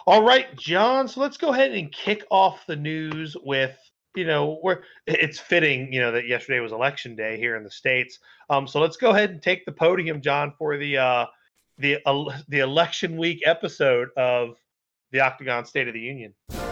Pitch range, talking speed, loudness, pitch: 130-180 Hz, 195 wpm, -23 LUFS, 150 Hz